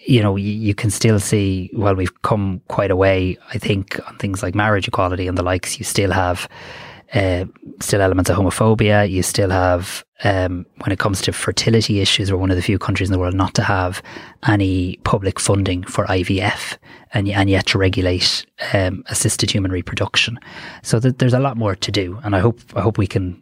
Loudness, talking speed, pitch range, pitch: -18 LUFS, 215 wpm, 95-105 Hz, 100 Hz